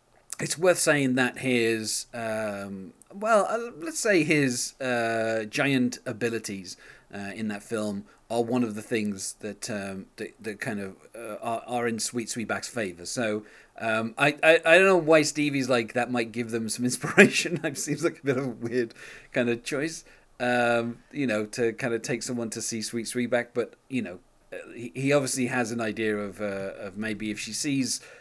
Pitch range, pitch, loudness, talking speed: 110-135 Hz, 120 Hz, -26 LUFS, 195 wpm